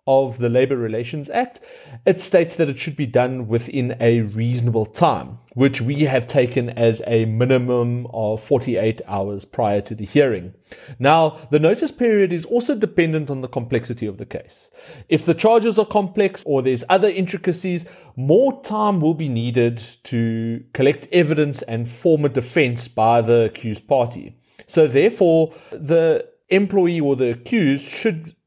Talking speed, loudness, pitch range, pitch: 160 wpm, -19 LUFS, 120-175 Hz, 135 Hz